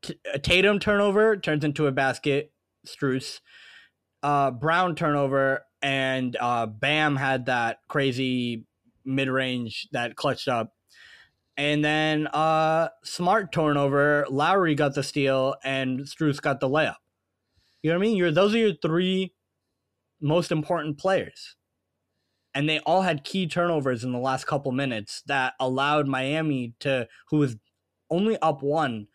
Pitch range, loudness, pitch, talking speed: 130-160 Hz, -25 LUFS, 140 Hz, 140 wpm